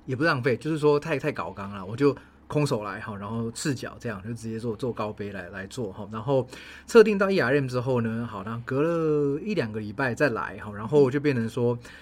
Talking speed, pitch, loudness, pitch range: 330 characters per minute, 120 Hz, -26 LUFS, 110-145 Hz